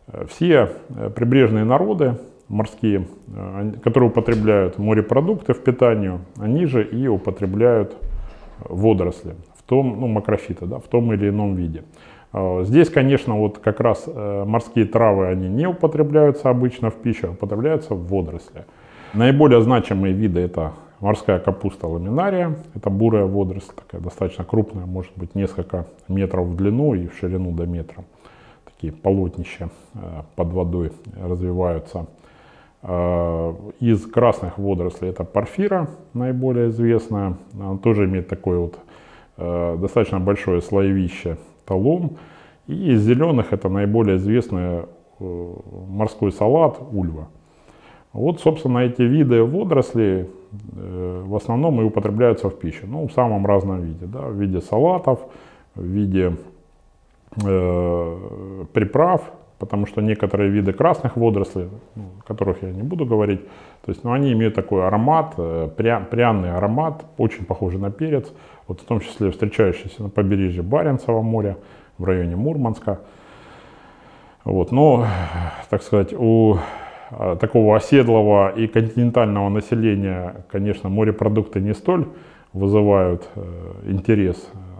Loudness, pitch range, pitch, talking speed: -20 LUFS, 95-120 Hz, 105 Hz, 125 wpm